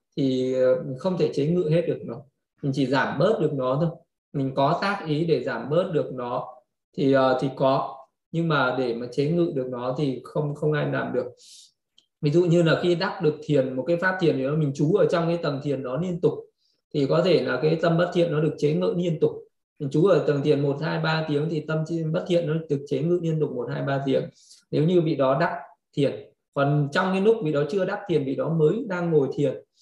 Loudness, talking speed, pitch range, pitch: -24 LUFS, 250 wpm, 140-170 Hz, 155 Hz